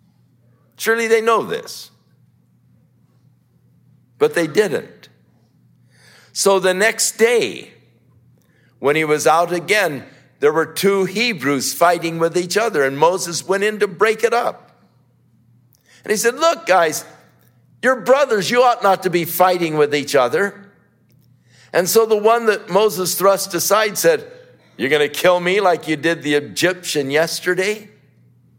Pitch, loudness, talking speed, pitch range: 185 Hz, -17 LUFS, 145 wpm, 155-225 Hz